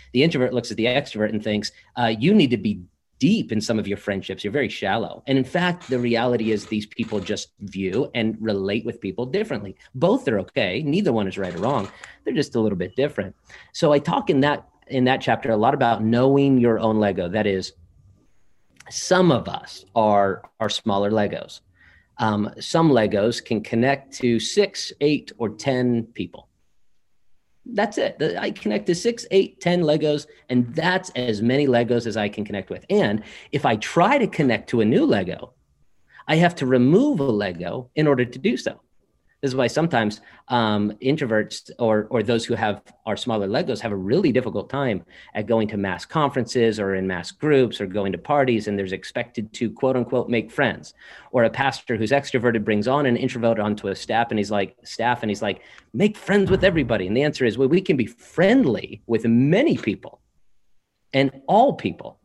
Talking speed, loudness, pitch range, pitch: 200 wpm, -22 LUFS, 105-135 Hz, 115 Hz